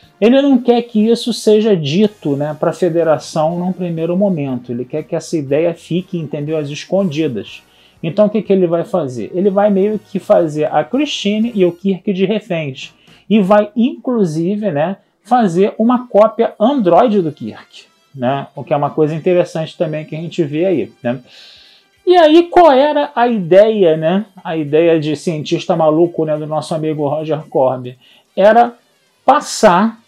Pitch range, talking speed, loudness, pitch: 155-215 Hz, 170 wpm, -14 LUFS, 180 Hz